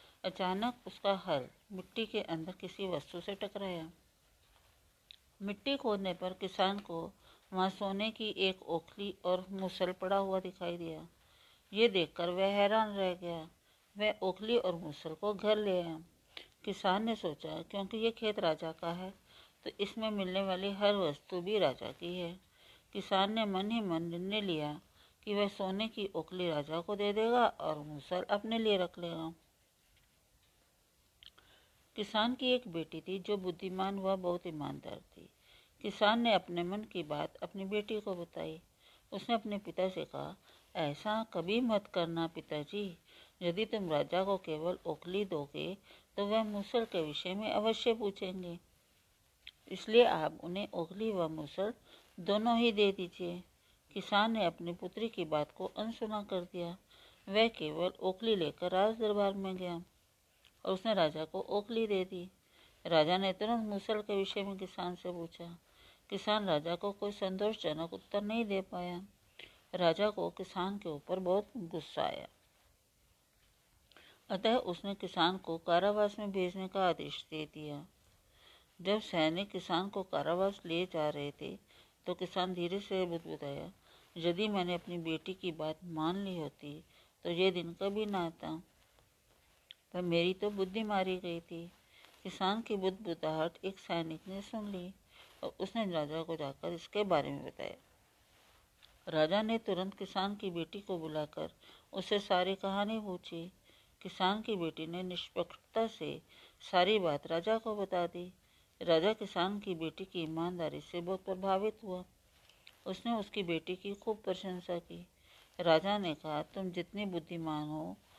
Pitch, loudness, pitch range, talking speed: 185 Hz, -36 LUFS, 170-205 Hz, 155 wpm